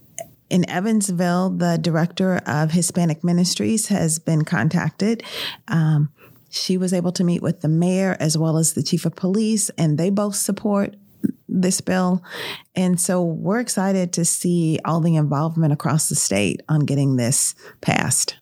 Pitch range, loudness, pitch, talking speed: 160-185 Hz, -20 LUFS, 175 Hz, 155 wpm